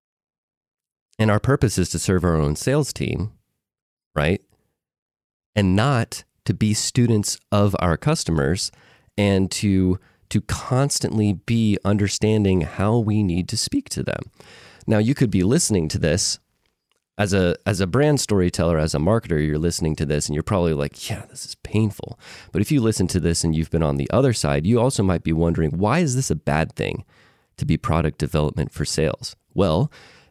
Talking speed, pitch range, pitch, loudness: 180 wpm, 85-115 Hz, 100 Hz, -21 LUFS